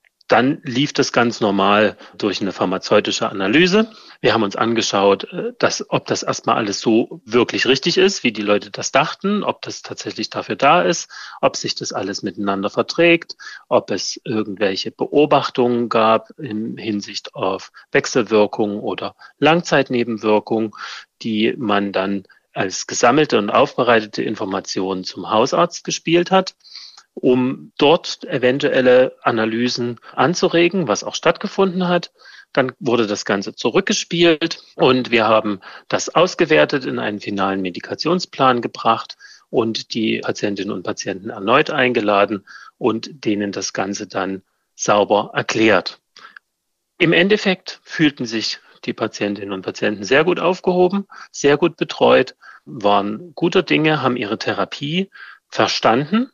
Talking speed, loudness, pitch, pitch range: 130 wpm, -18 LUFS, 125 Hz, 105-170 Hz